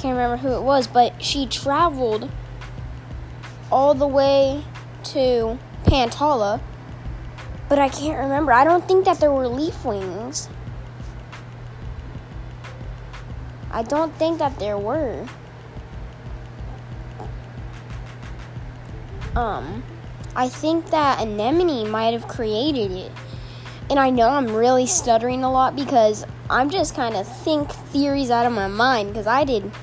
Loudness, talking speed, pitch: -20 LUFS, 125 wpm, 230 Hz